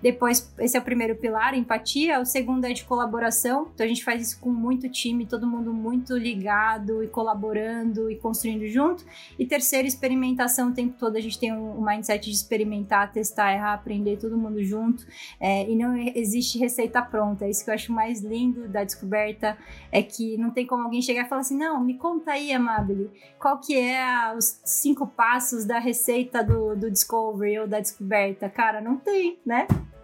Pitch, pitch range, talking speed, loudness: 230 Hz, 215-250 Hz, 195 wpm, -25 LUFS